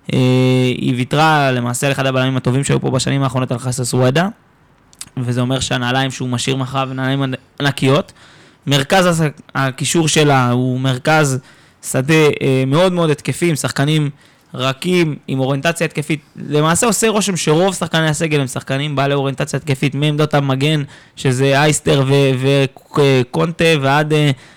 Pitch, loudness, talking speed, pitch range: 140 Hz, -15 LUFS, 145 wpm, 130-155 Hz